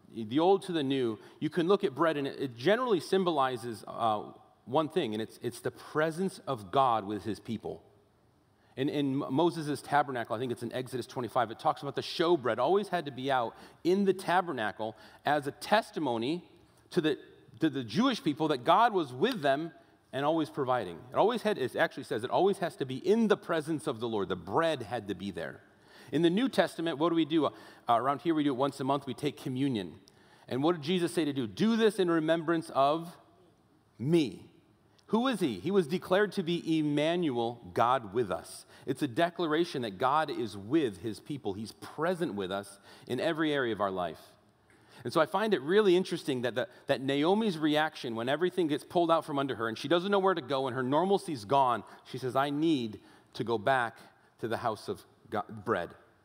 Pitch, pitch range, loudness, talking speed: 150 Hz, 125-175 Hz, -31 LUFS, 210 wpm